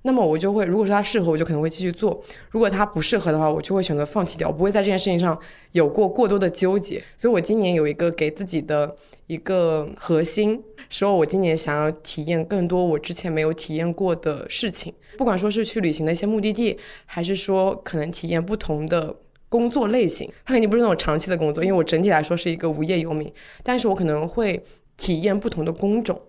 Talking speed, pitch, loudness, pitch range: 350 characters per minute, 180 Hz, -22 LUFS, 160-210 Hz